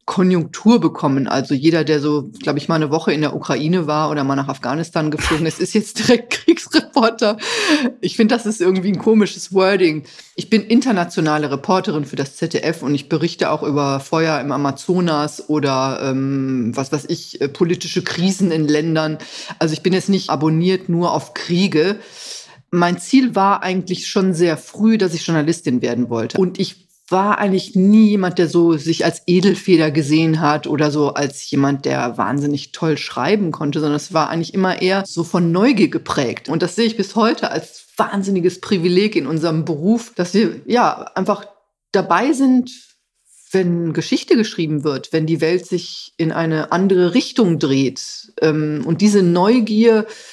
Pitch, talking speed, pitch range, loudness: 170 Hz, 170 wpm, 155-195 Hz, -17 LUFS